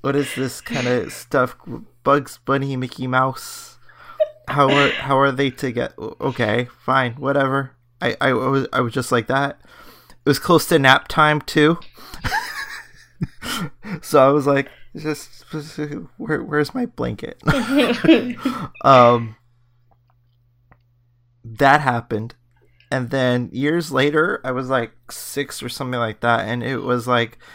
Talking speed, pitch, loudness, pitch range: 140 wpm, 130 Hz, -19 LUFS, 120-145 Hz